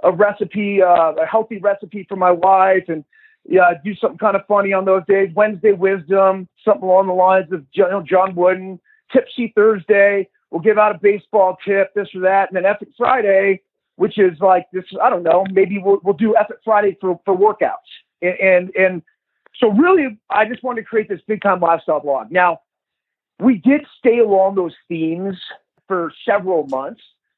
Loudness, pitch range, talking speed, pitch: -16 LUFS, 185-215 Hz, 185 wpm, 195 Hz